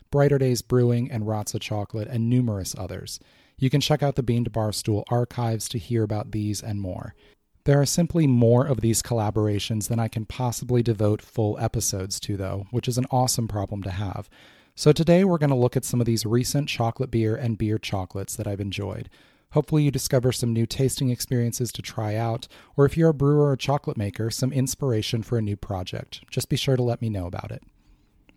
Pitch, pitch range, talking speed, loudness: 115 Hz, 105-130 Hz, 210 wpm, -24 LUFS